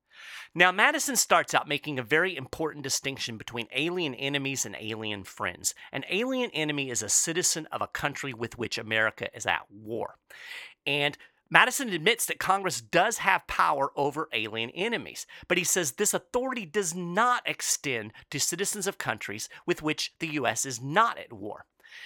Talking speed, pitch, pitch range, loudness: 165 wpm, 155 Hz, 130-200 Hz, -27 LUFS